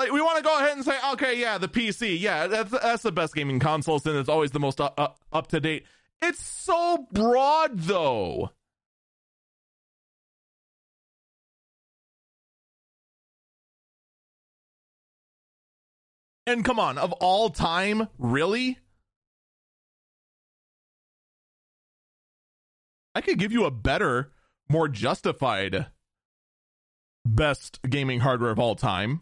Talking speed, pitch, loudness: 105 wpm, 160 Hz, -25 LUFS